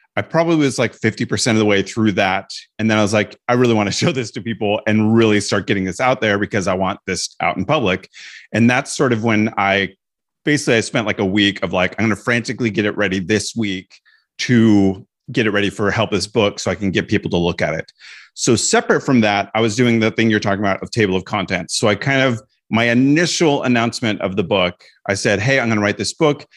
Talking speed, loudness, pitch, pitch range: 255 wpm, -17 LUFS, 110 Hz, 100-120 Hz